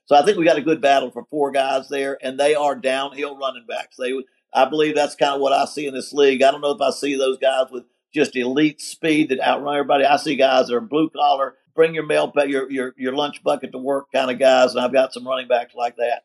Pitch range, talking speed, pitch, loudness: 130-145 Hz, 270 wpm, 135 Hz, -19 LUFS